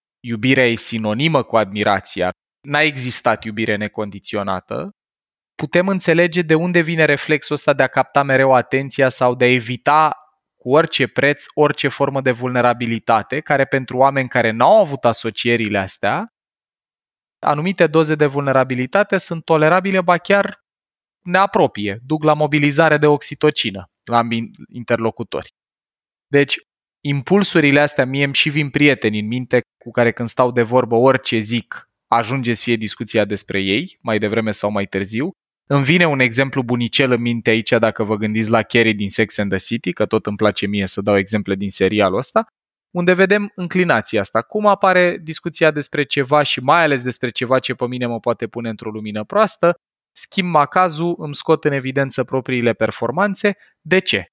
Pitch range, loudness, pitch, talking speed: 115-155 Hz, -17 LUFS, 130 Hz, 160 wpm